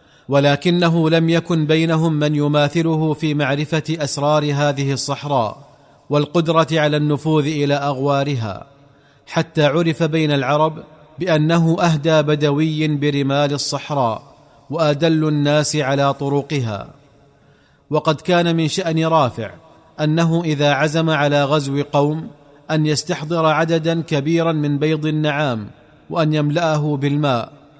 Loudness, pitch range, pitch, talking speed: -18 LUFS, 145-160 Hz, 150 Hz, 110 wpm